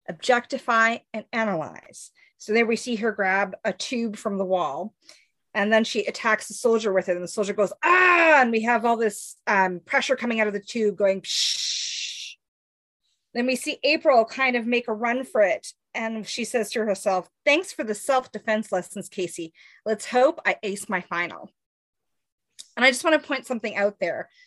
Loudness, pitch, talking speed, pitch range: -23 LUFS, 225 Hz, 195 wpm, 200-250 Hz